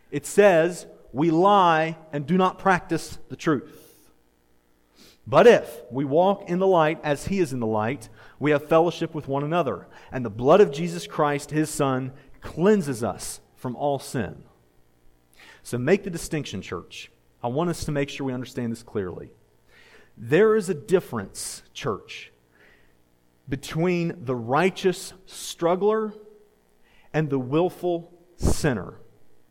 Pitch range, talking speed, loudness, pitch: 120-175 Hz, 140 wpm, -24 LUFS, 150 Hz